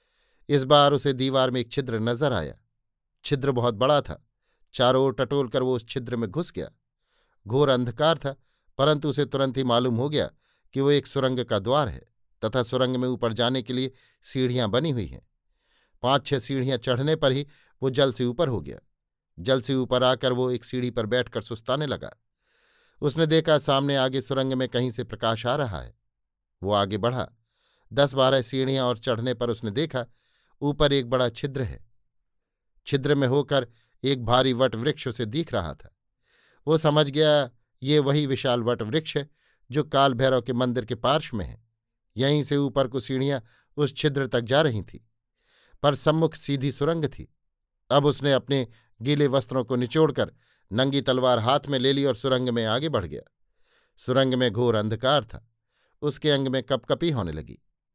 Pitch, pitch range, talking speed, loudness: 130 Hz, 120-140 Hz, 180 wpm, -25 LUFS